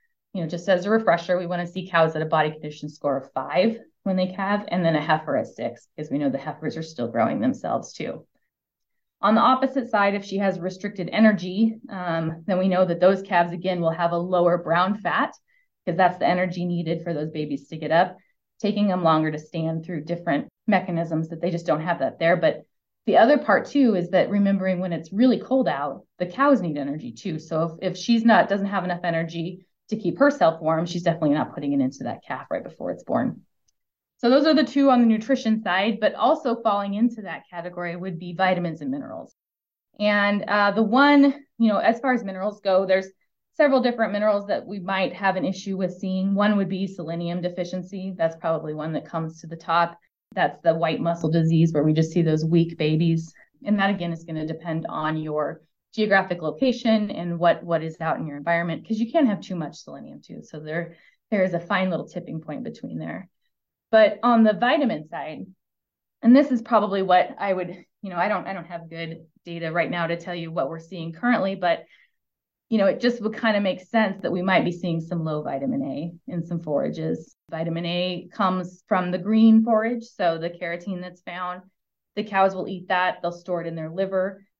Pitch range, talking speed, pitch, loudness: 165-215 Hz, 220 wpm, 180 Hz, -23 LUFS